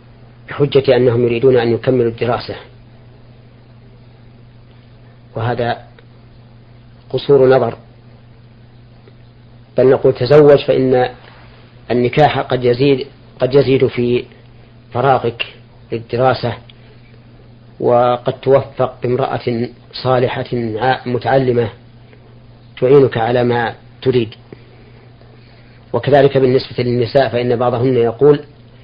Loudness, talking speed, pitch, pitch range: -14 LUFS, 75 wpm, 120 Hz, 120-125 Hz